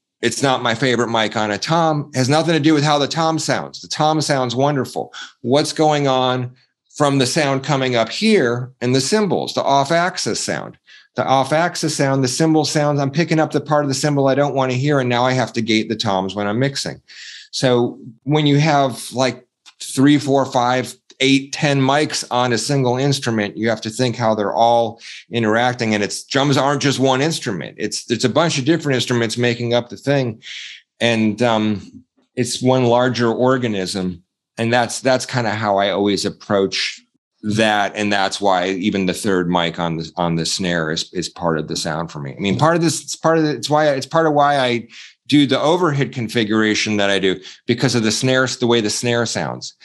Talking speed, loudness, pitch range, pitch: 215 wpm, -18 LUFS, 110-140 Hz, 125 Hz